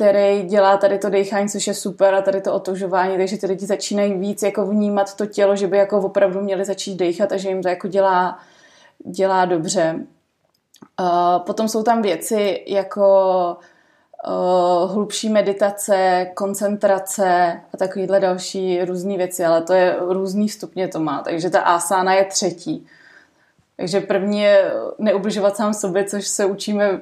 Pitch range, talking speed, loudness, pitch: 185-205 Hz, 160 wpm, -19 LUFS, 195 Hz